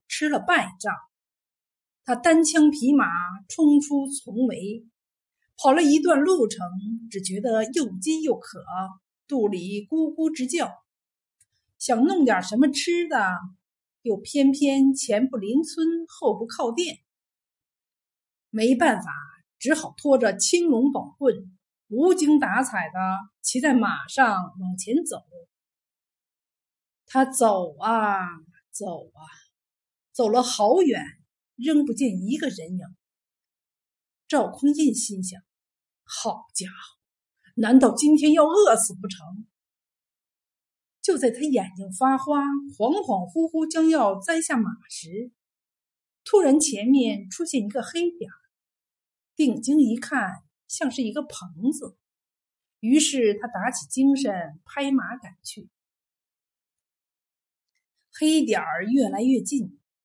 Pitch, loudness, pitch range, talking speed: 255 Hz, -23 LUFS, 210-295 Hz, 160 characters per minute